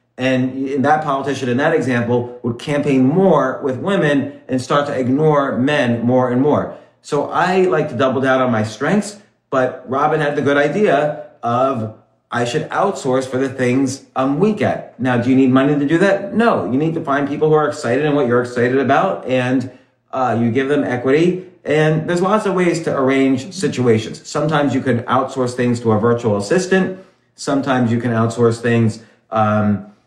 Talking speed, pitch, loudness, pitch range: 190 wpm, 130 Hz, -17 LUFS, 125-150 Hz